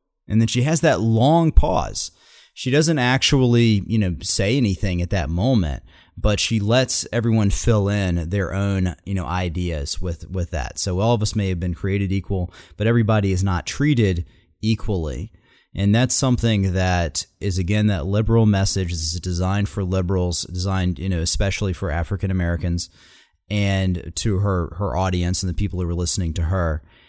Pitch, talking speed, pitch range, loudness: 95 Hz, 175 wpm, 90-105 Hz, -20 LUFS